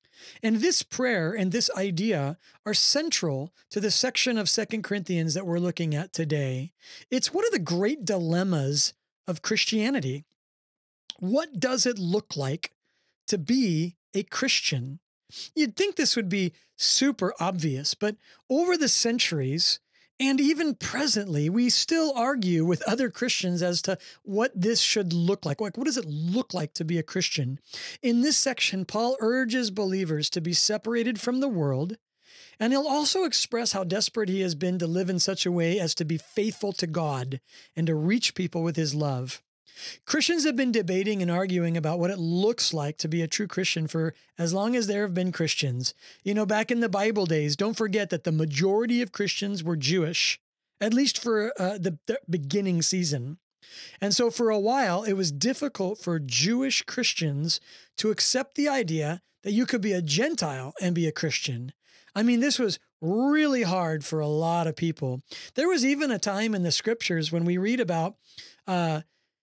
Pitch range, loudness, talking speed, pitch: 165-235 Hz, -26 LUFS, 180 wpm, 190 Hz